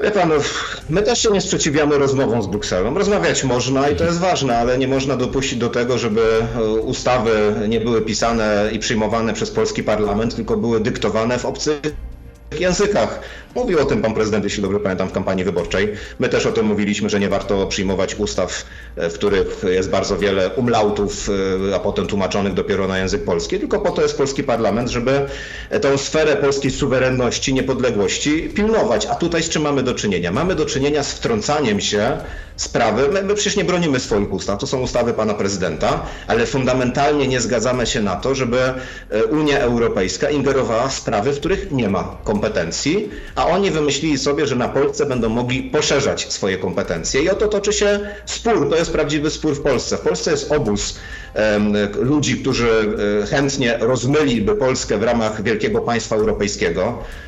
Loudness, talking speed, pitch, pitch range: -18 LUFS, 175 wpm, 130 Hz, 110-145 Hz